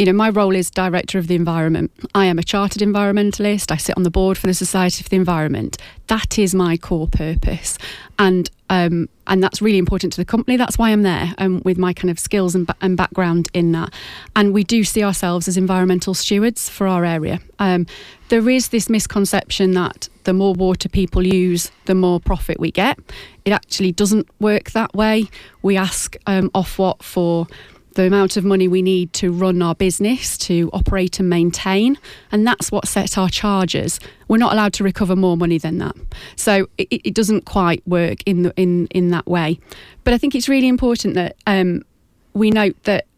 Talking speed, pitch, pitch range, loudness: 200 wpm, 190 Hz, 180-205 Hz, -17 LUFS